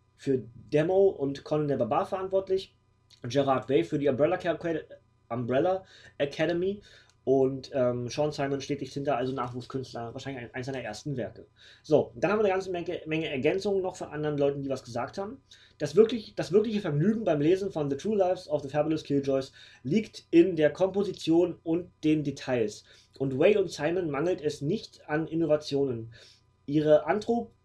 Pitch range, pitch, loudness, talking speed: 130-180 Hz, 150 Hz, -28 LUFS, 170 wpm